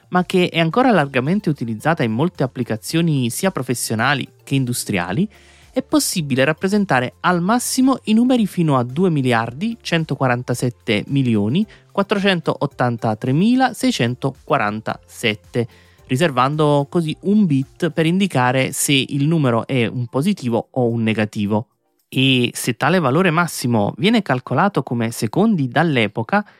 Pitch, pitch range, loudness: 140 Hz, 120-180 Hz, -18 LUFS